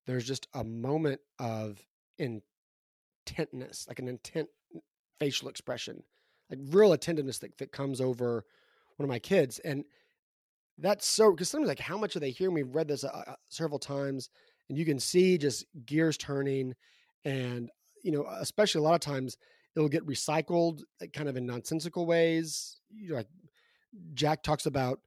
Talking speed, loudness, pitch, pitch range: 165 wpm, -31 LUFS, 145 Hz, 130-165 Hz